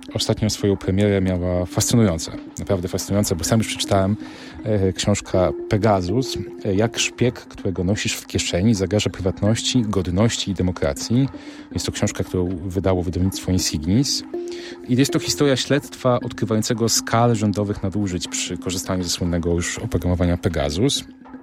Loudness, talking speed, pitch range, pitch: -21 LUFS, 135 wpm, 90-120 Hz, 105 Hz